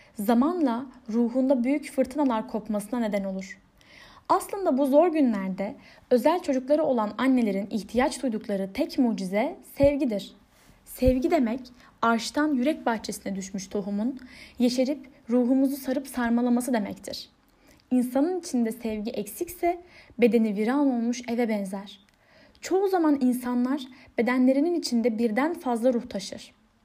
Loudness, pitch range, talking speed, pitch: -26 LUFS, 225-285 Hz, 110 wpm, 250 Hz